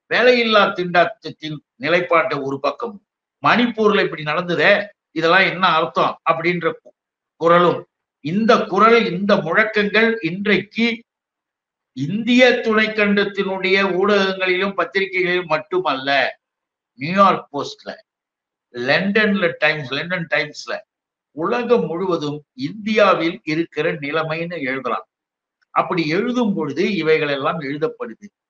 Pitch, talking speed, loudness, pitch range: 185 Hz, 85 wpm, -18 LUFS, 160-215 Hz